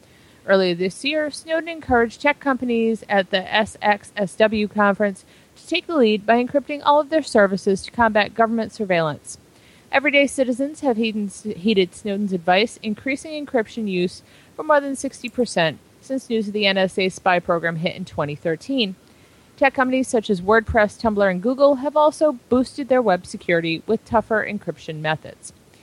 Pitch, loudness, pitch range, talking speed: 220 Hz, -20 LUFS, 195-265 Hz, 155 wpm